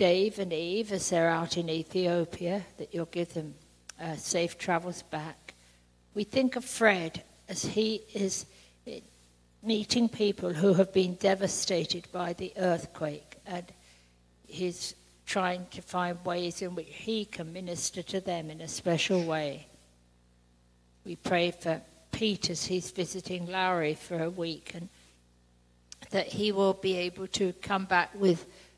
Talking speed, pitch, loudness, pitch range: 145 wpm, 175 Hz, -31 LUFS, 155-190 Hz